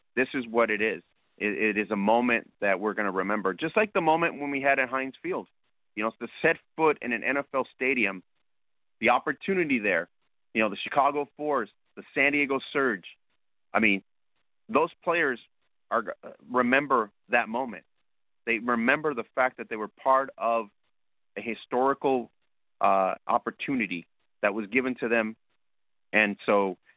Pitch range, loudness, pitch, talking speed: 105-135 Hz, -27 LUFS, 120 Hz, 160 wpm